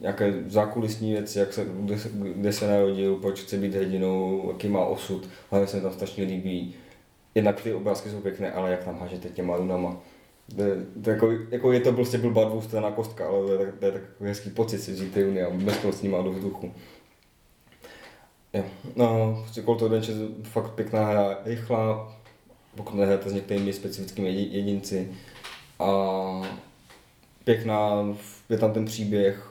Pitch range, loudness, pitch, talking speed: 95-110 Hz, -27 LUFS, 100 Hz, 170 wpm